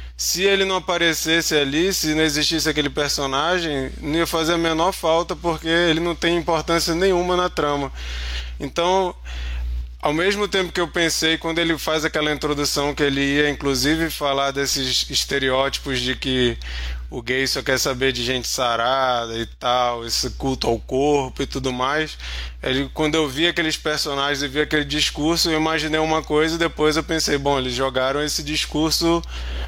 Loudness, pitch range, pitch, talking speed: -20 LUFS, 130-165 Hz, 150 Hz, 170 wpm